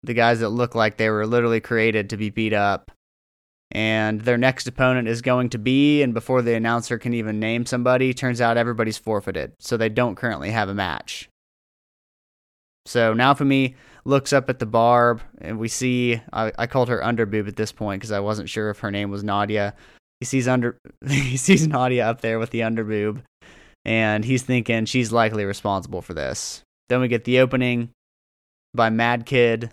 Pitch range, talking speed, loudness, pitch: 110-125 Hz, 190 wpm, -21 LUFS, 115 Hz